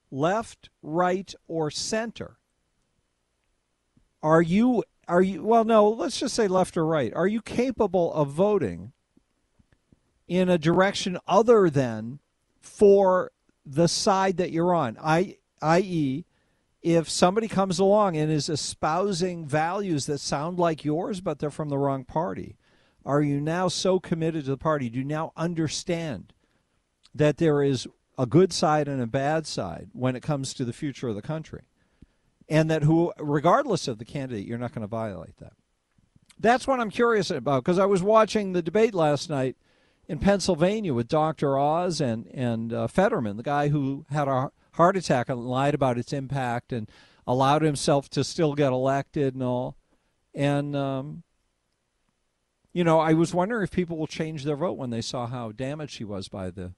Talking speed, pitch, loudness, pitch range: 170 wpm, 155 Hz, -25 LUFS, 130-180 Hz